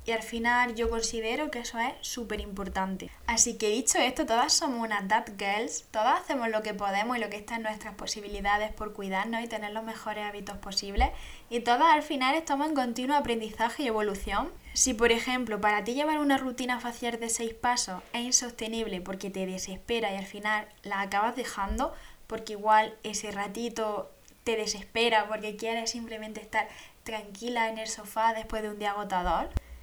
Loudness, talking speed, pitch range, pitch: -29 LUFS, 180 wpm, 210-240 Hz, 220 Hz